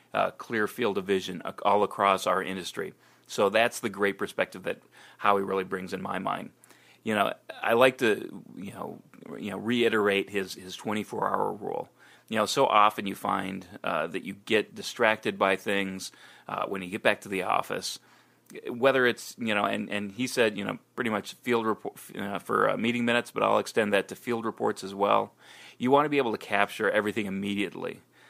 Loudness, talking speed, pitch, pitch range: -28 LUFS, 205 wpm, 100 Hz, 95-115 Hz